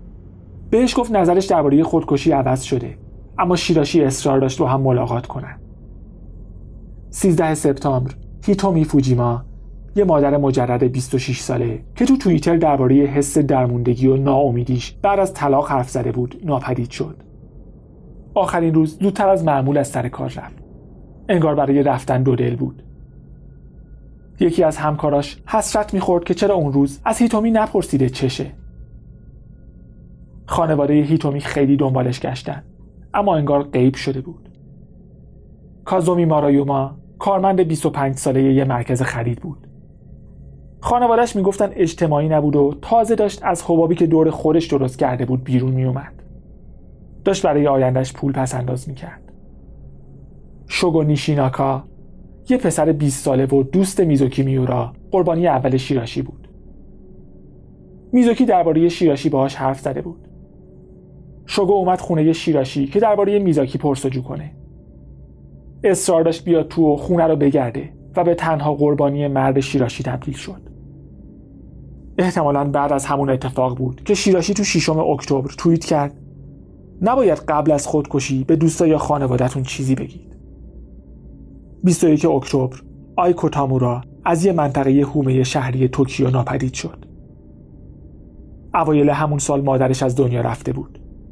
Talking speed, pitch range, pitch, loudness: 130 wpm, 130-165 Hz, 140 Hz, -18 LUFS